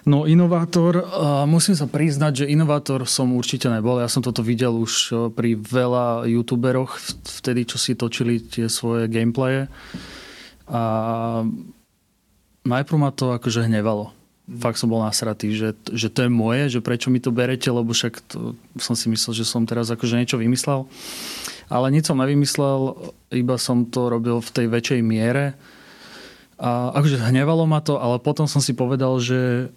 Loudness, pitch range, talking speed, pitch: -21 LUFS, 115-135 Hz, 160 wpm, 125 Hz